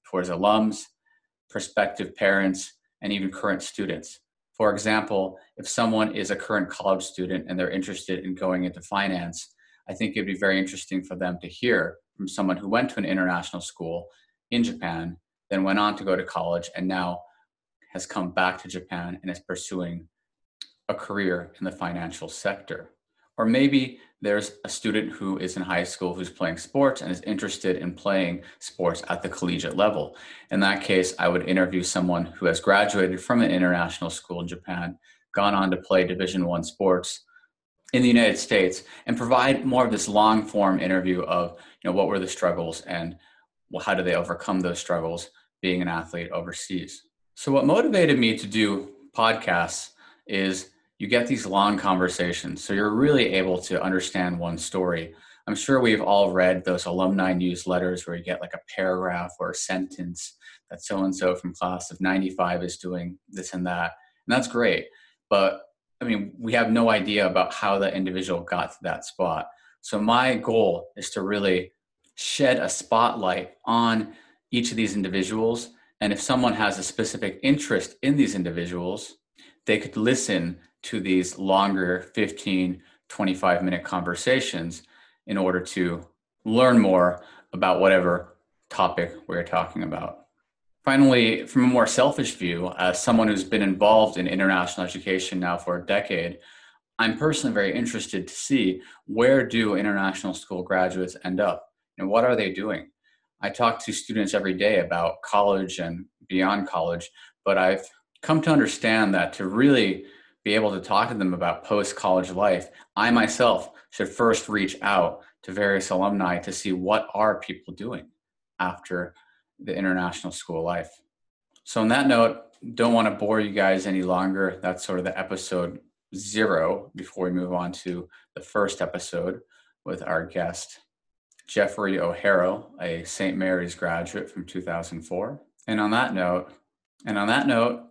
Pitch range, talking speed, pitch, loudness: 90-105 Hz, 170 wpm, 95 Hz, -24 LUFS